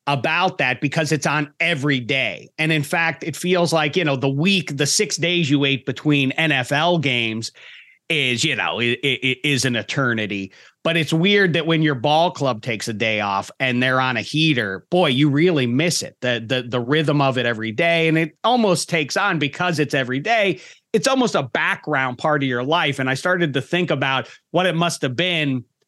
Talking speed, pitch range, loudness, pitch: 215 wpm, 130-170 Hz, -19 LUFS, 150 Hz